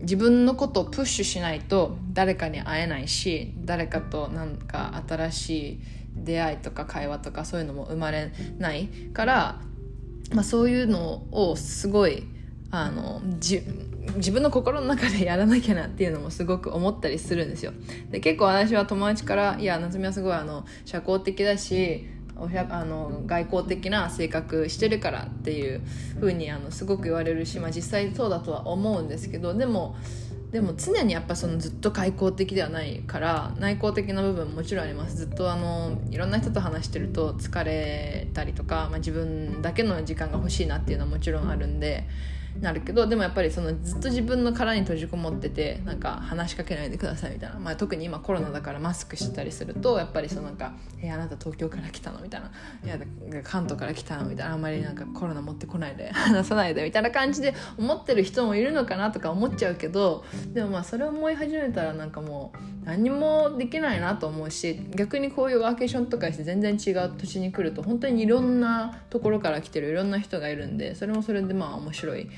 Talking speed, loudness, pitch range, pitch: 415 characters per minute, -27 LUFS, 150-210 Hz, 175 Hz